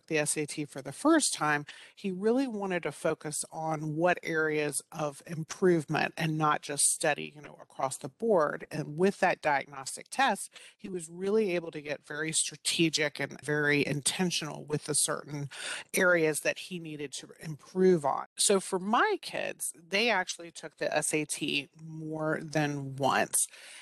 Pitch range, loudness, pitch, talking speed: 150-180 Hz, -30 LUFS, 160 Hz, 160 wpm